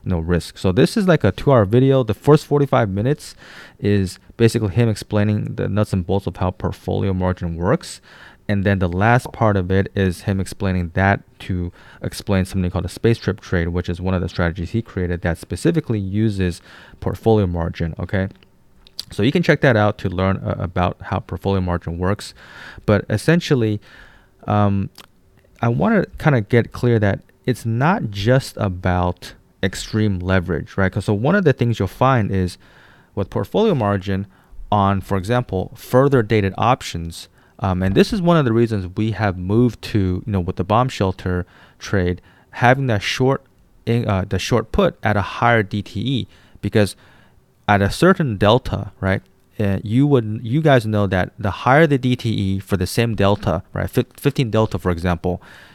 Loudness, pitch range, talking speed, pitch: -19 LUFS, 95-120 Hz, 180 wpm, 100 Hz